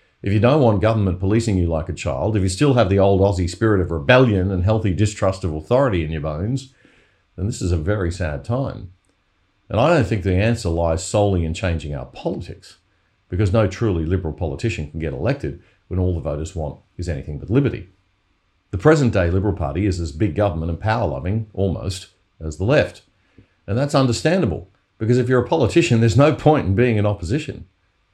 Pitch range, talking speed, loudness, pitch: 90-110 Hz, 205 wpm, -20 LUFS, 95 Hz